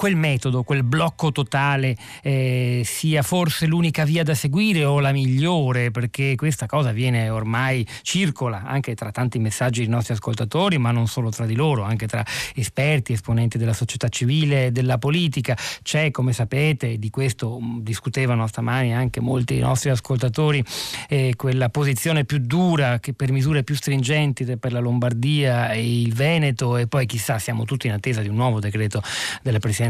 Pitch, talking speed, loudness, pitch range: 130 Hz, 170 wpm, -21 LUFS, 120-145 Hz